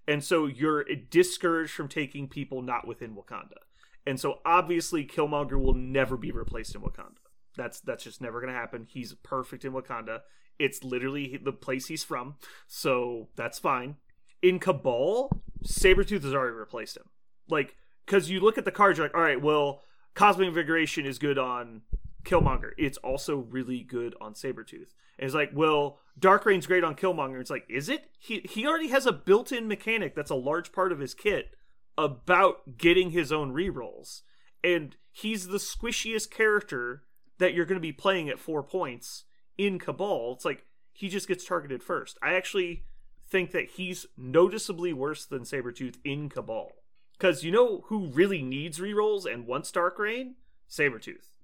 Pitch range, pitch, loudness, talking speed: 135-195 Hz, 165 Hz, -28 LUFS, 175 wpm